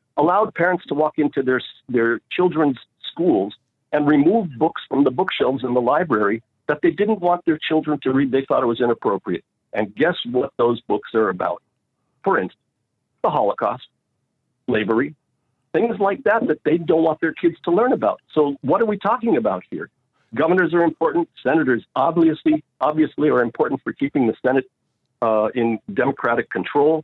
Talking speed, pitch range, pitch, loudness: 175 wpm, 130-175 Hz, 155 Hz, -20 LUFS